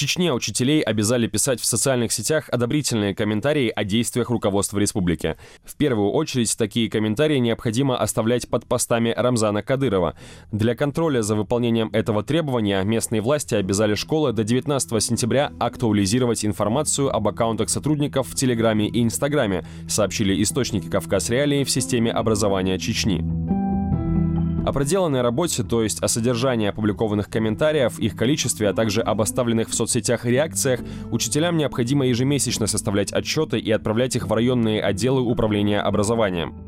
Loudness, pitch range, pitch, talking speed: -21 LUFS, 105-130 Hz, 115 Hz, 140 wpm